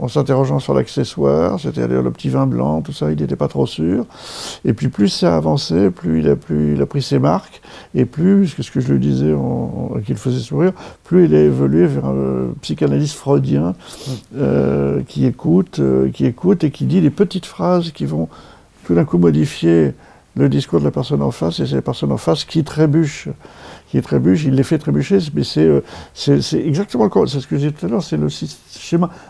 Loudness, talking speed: -17 LUFS, 225 wpm